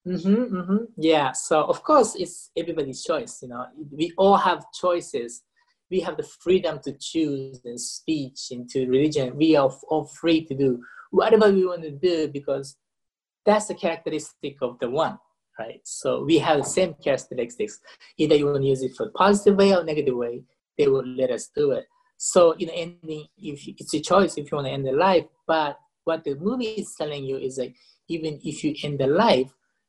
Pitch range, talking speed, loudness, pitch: 140-185 Hz, 205 wpm, -23 LUFS, 155 Hz